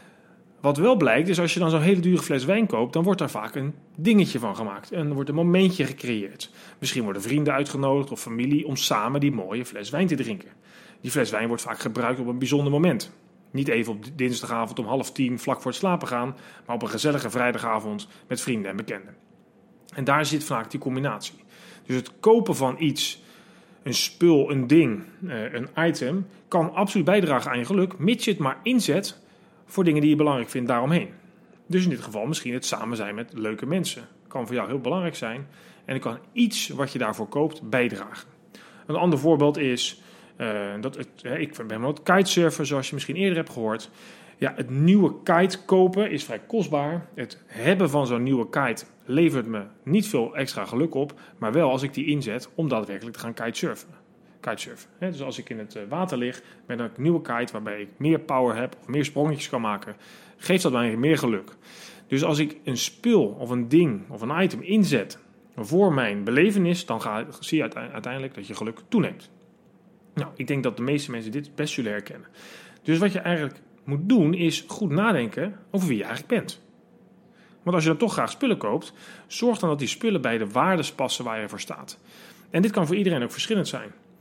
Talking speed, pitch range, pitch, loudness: 205 wpm, 125-185 Hz, 150 Hz, -25 LUFS